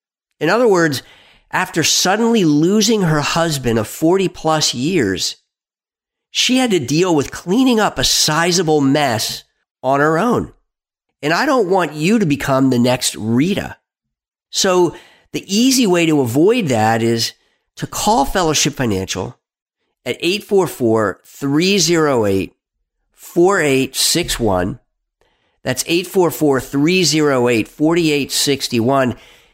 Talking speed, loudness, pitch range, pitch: 105 wpm, -15 LUFS, 130-175 Hz, 150 Hz